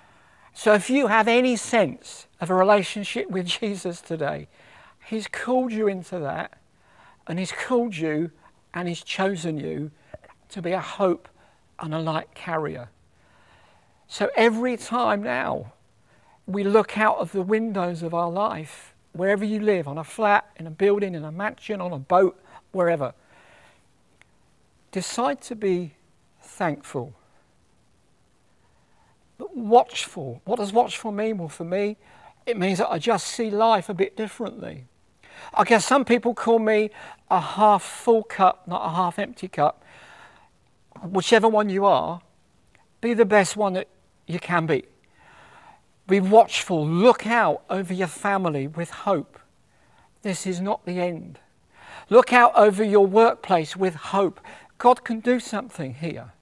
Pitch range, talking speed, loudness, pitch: 170-220 Hz, 145 wpm, -23 LUFS, 195 Hz